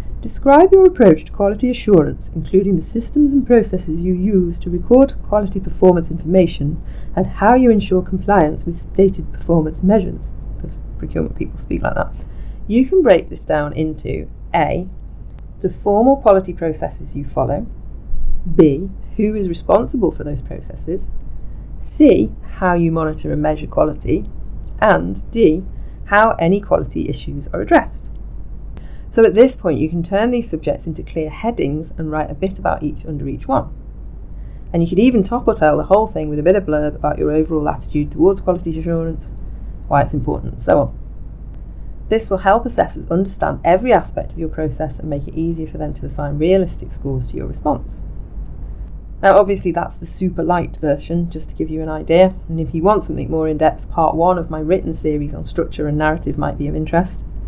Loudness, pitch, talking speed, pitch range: -17 LUFS, 170 Hz, 185 wpm, 155-195 Hz